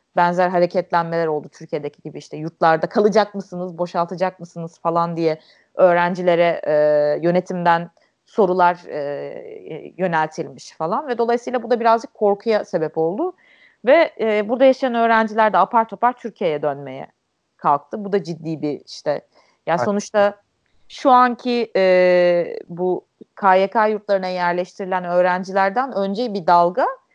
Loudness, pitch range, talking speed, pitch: -19 LUFS, 170-215 Hz, 125 wpm, 185 Hz